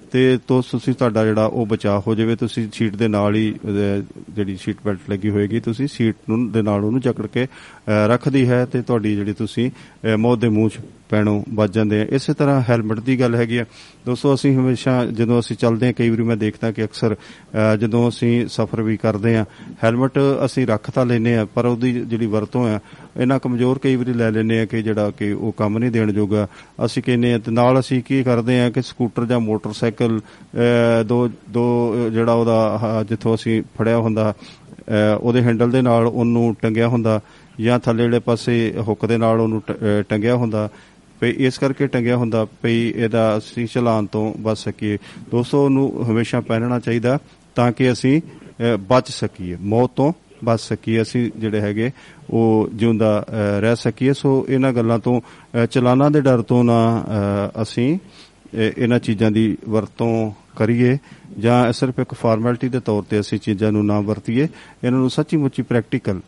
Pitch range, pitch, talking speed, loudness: 110-125 Hz, 115 Hz, 170 wpm, -19 LUFS